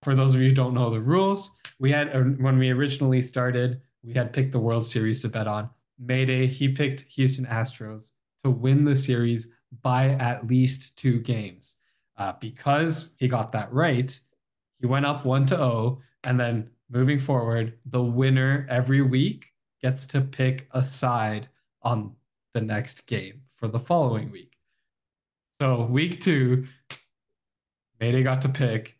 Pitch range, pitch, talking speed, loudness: 120-135 Hz, 130 Hz, 160 wpm, -25 LUFS